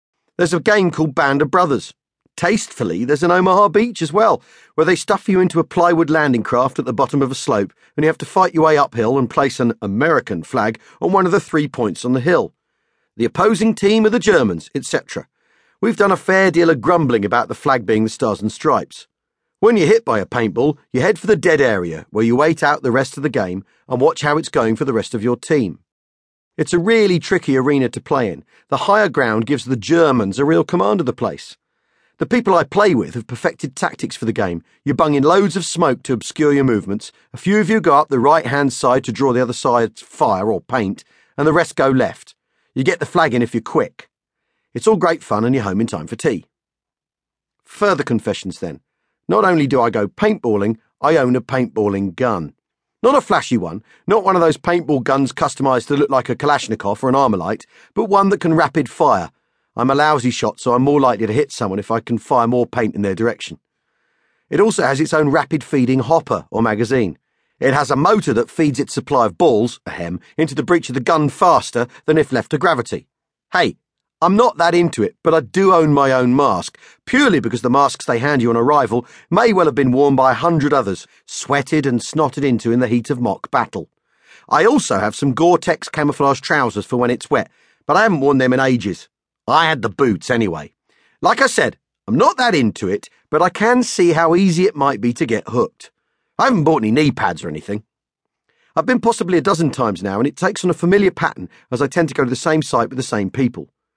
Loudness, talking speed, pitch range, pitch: -16 LUFS, 230 wpm, 120-175 Hz, 145 Hz